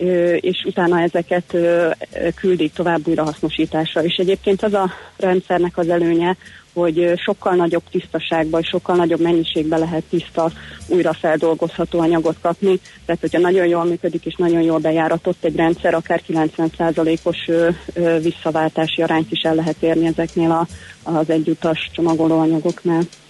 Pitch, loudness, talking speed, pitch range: 170 Hz, -18 LUFS, 130 wpm, 165-175 Hz